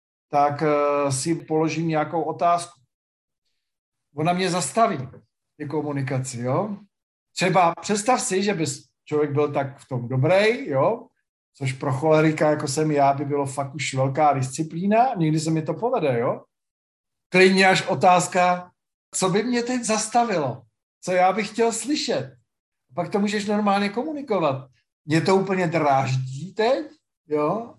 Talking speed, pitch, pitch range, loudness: 140 wpm, 155 Hz, 140-190 Hz, -22 LUFS